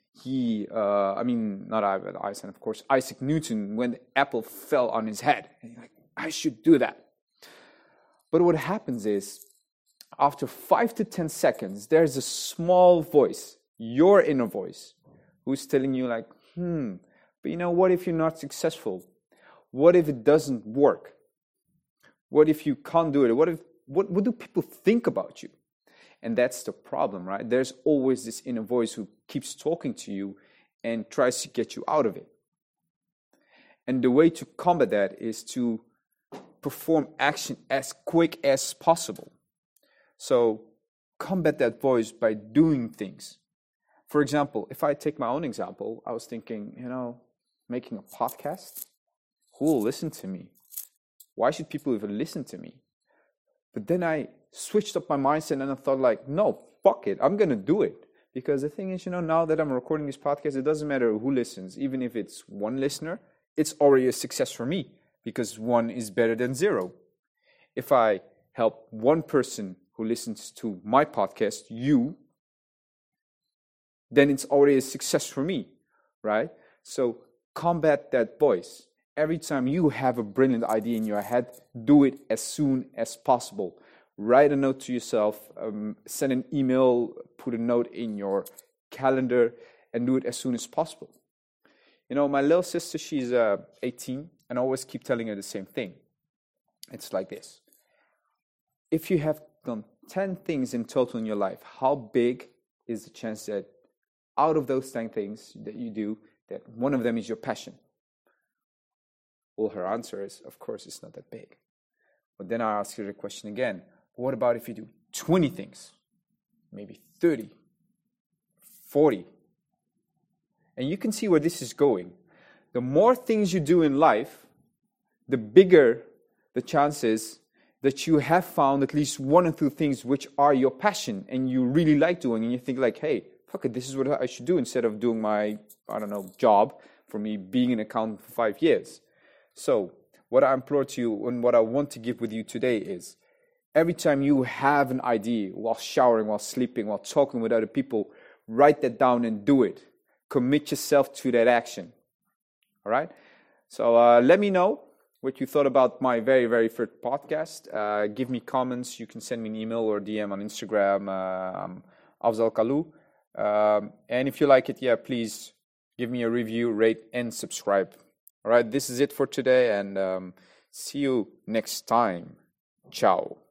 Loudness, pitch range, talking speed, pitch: -26 LUFS, 115-155 Hz, 180 wpm, 130 Hz